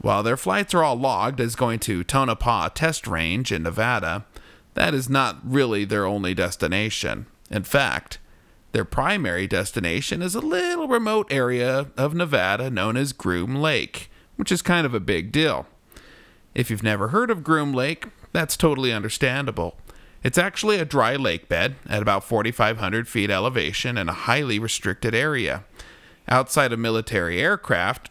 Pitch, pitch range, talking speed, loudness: 125 Hz, 105-145 Hz, 160 wpm, -23 LUFS